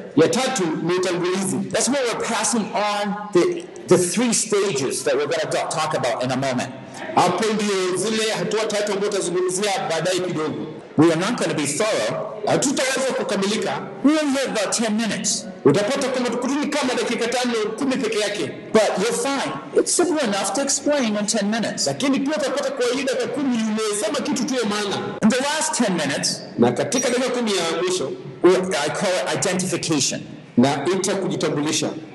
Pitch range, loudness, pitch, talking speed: 190-260 Hz, -21 LUFS, 215 Hz, 120 wpm